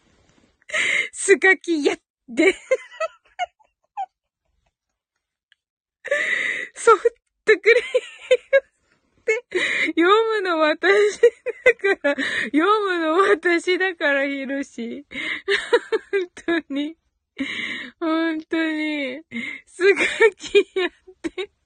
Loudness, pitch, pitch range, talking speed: -20 LUFS, 370 Hz, 320-435 Hz, 130 characters per minute